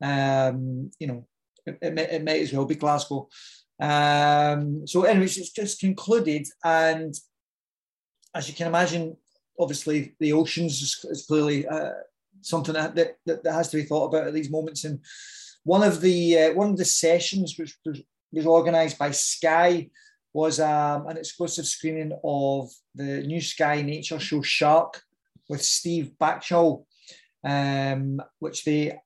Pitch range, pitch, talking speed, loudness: 145-170 Hz, 160 Hz, 155 wpm, -24 LUFS